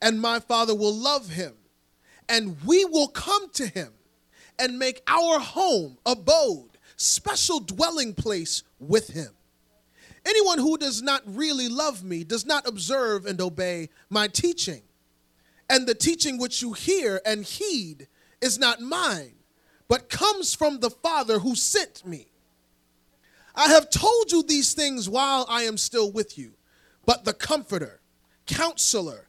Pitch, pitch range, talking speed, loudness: 235 Hz, 180-300 Hz, 145 wpm, -23 LUFS